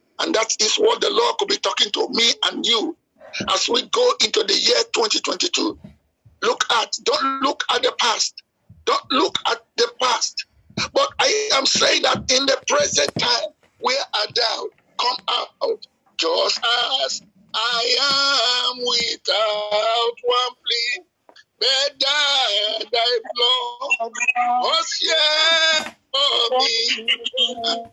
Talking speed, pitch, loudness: 125 wpm, 275 Hz, -18 LUFS